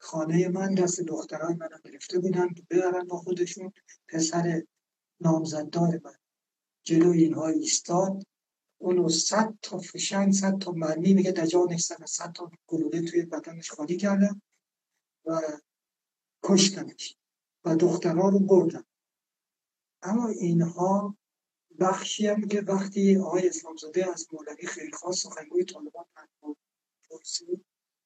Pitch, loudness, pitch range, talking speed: 175 Hz, -27 LUFS, 165-195 Hz, 115 wpm